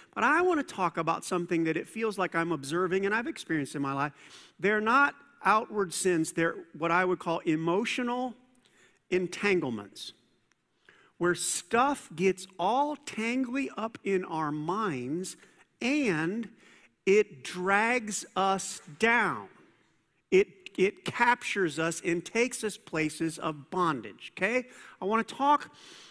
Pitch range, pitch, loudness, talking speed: 170-235 Hz, 190 Hz, -29 LUFS, 135 wpm